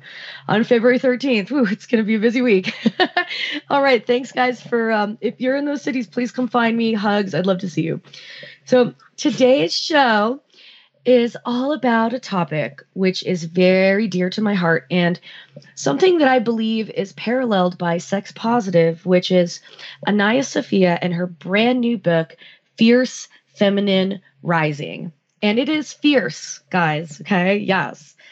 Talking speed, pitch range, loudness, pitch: 160 wpm, 180-250 Hz, -18 LUFS, 220 Hz